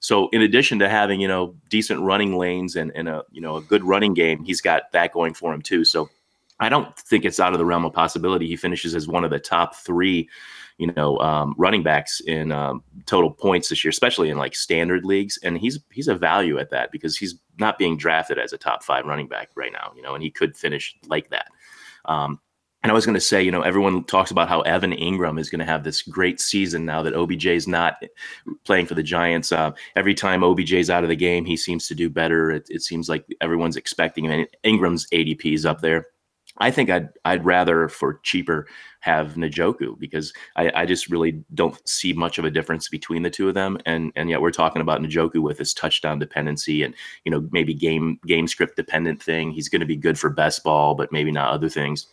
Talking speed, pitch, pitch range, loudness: 235 wpm, 85 Hz, 80-90 Hz, -21 LUFS